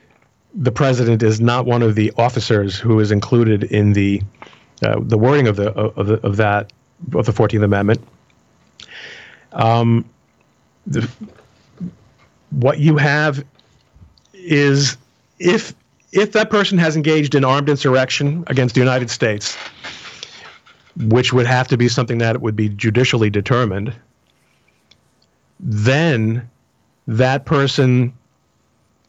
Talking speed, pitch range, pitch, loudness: 120 wpm, 110-135 Hz, 125 Hz, -16 LUFS